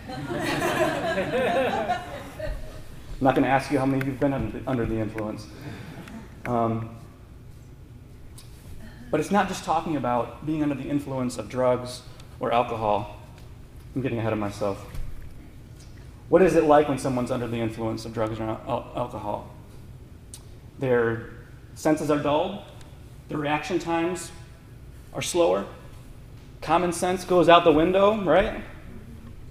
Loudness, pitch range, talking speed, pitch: -25 LUFS, 115-145 Hz, 130 wpm, 120 Hz